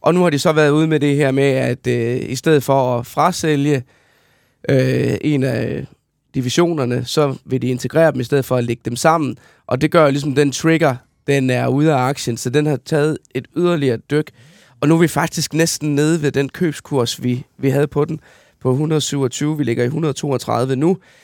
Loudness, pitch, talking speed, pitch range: -17 LUFS, 140 Hz, 210 wpm, 130-155 Hz